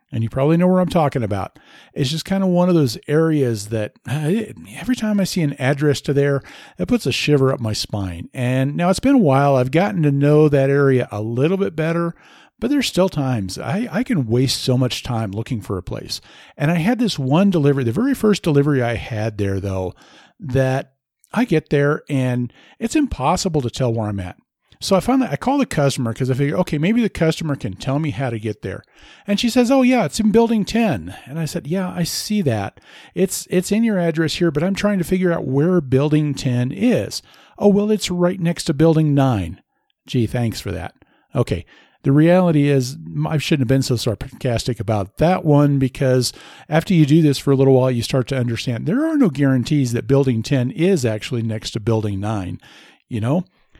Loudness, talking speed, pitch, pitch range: -19 LUFS, 215 wpm, 145 Hz, 125-180 Hz